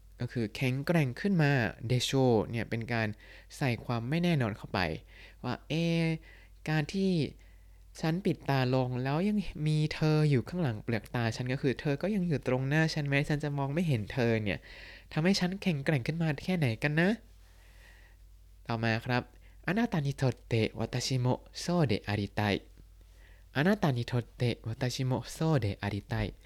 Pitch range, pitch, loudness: 110-155 Hz, 130 Hz, -31 LUFS